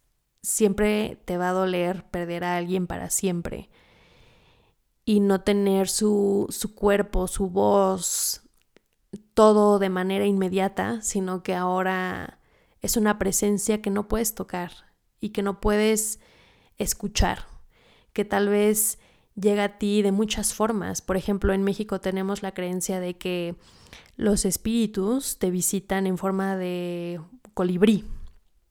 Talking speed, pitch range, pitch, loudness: 130 wpm, 185-210 Hz, 195 Hz, -24 LUFS